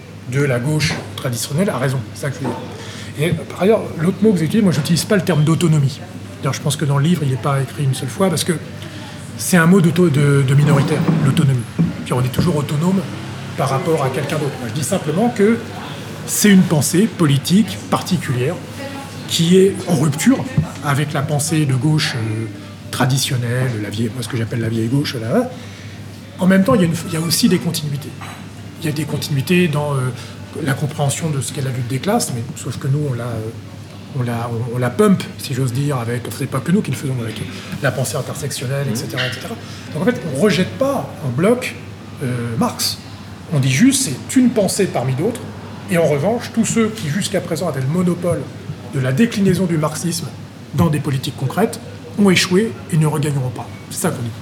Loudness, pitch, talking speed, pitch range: -18 LUFS, 145 Hz, 215 wpm, 125-170 Hz